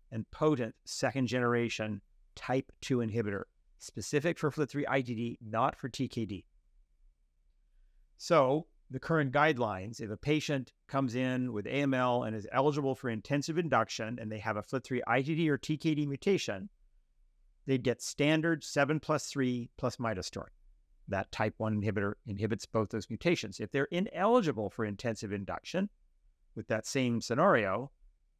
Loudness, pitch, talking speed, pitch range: -33 LUFS, 120 Hz, 140 wpm, 110-140 Hz